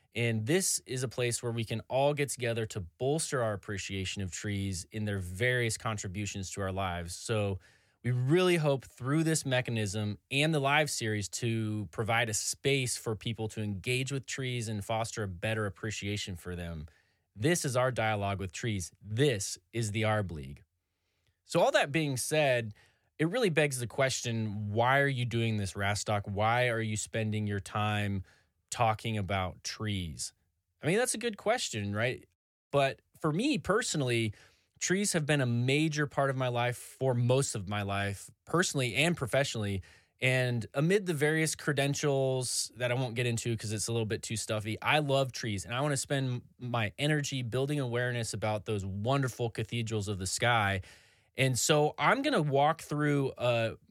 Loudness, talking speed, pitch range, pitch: -31 LUFS, 180 wpm, 105-135 Hz, 115 Hz